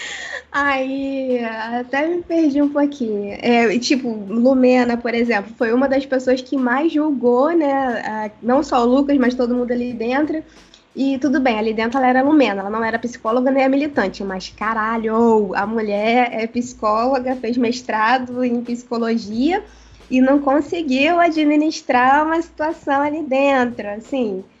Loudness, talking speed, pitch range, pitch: -18 LUFS, 155 wpm, 230-280 Hz, 255 Hz